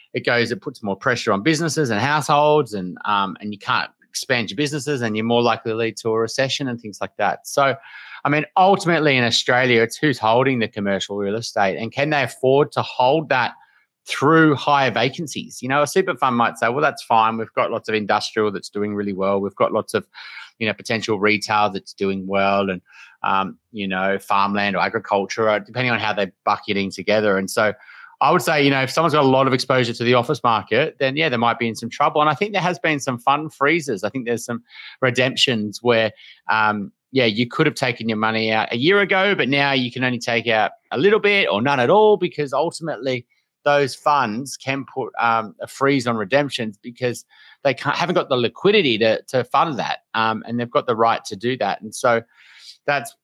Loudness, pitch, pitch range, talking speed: -19 LUFS, 120 Hz, 105-145 Hz, 225 wpm